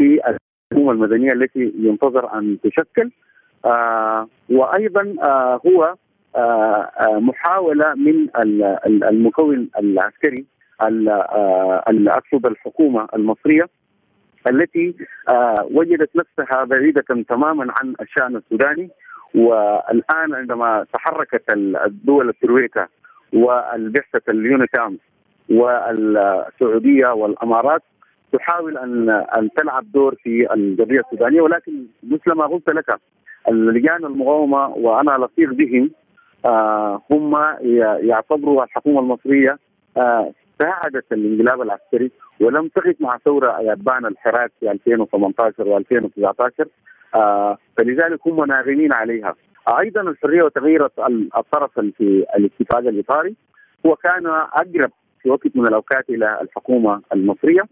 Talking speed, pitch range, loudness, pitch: 95 wpm, 110-155 Hz, -17 LUFS, 130 Hz